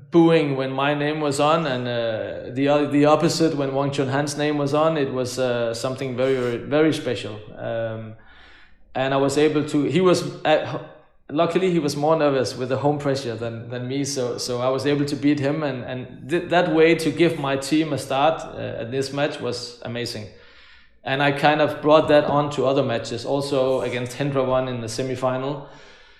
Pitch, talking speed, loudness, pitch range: 140 Hz, 205 wpm, -22 LUFS, 125-150 Hz